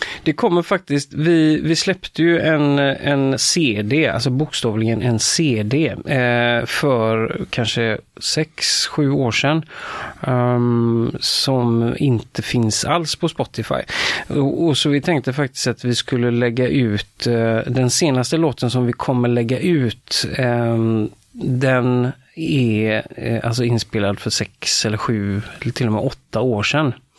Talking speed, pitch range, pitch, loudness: 140 wpm, 115-145 Hz, 125 Hz, -18 LUFS